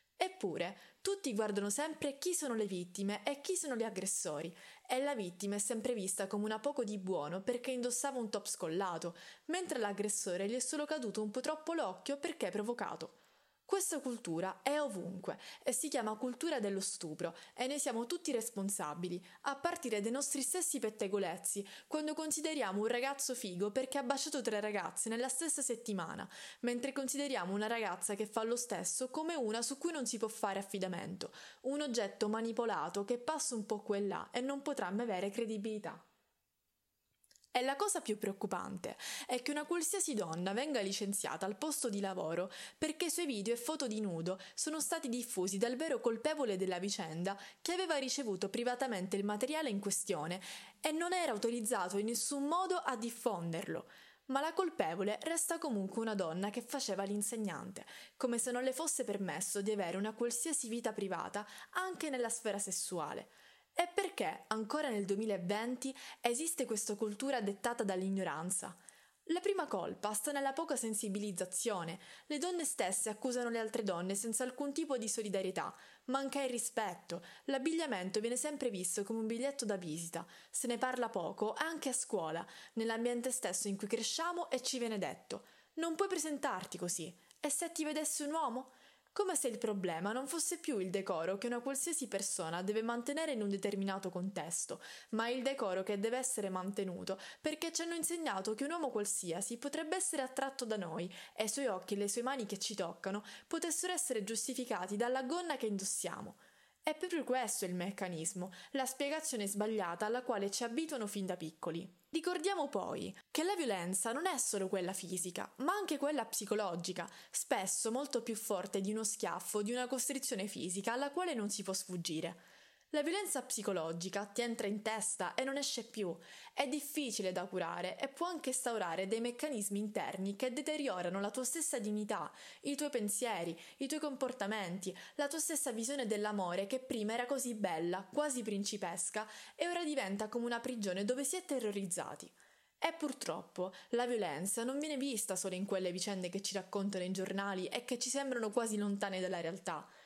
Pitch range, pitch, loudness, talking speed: 200-275 Hz, 230 Hz, -38 LUFS, 175 wpm